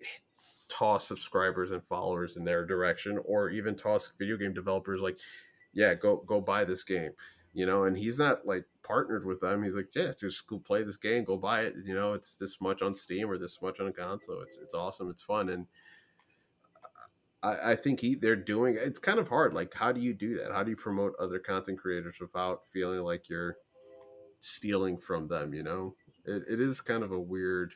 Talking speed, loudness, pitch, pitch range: 210 wpm, -32 LUFS, 95 Hz, 90-110 Hz